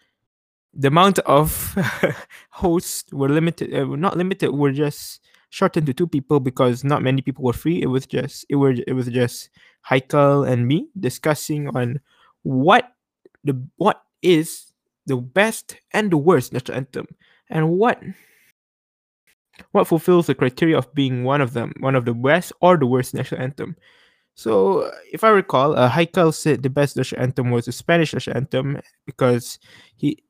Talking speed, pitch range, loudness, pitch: 165 wpm, 130-170 Hz, -20 LUFS, 145 Hz